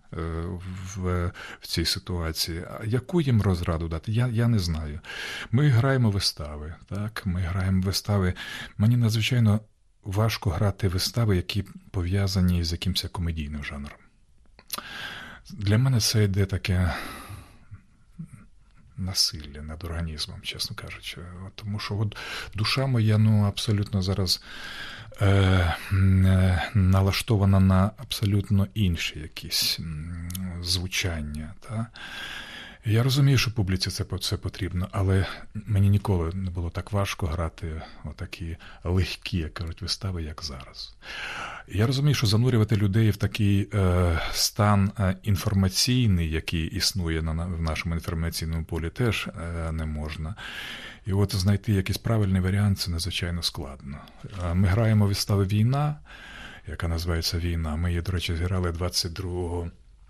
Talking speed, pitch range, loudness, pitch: 125 wpm, 85-105 Hz, -26 LUFS, 95 Hz